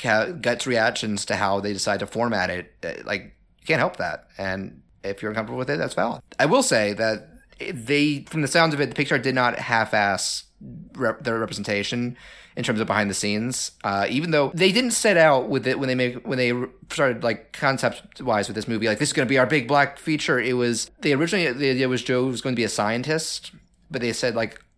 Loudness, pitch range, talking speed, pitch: -23 LUFS, 105-140 Hz, 235 wpm, 120 Hz